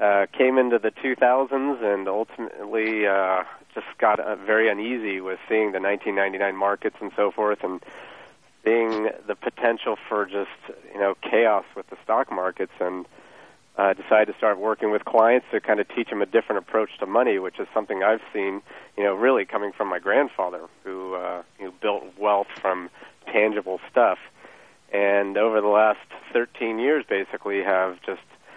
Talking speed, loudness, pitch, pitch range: 170 wpm, -23 LUFS, 100 Hz, 95-110 Hz